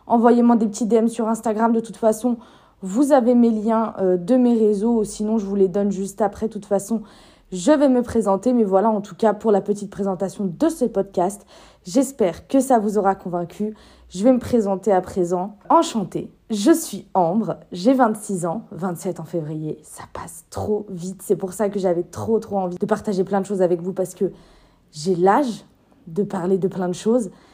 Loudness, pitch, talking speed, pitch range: -20 LUFS, 205 Hz, 205 wpm, 190-230 Hz